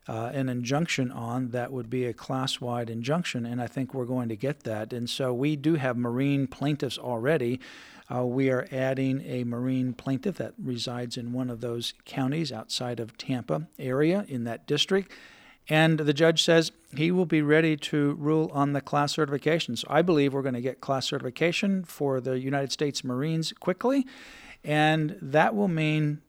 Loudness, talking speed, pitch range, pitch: -27 LUFS, 185 wpm, 125-155 Hz, 135 Hz